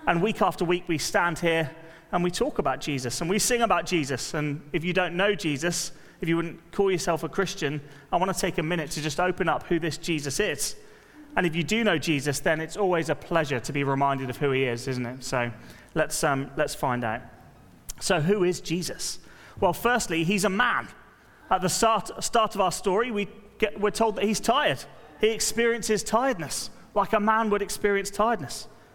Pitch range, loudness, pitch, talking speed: 150-205 Hz, -26 LUFS, 175 Hz, 210 wpm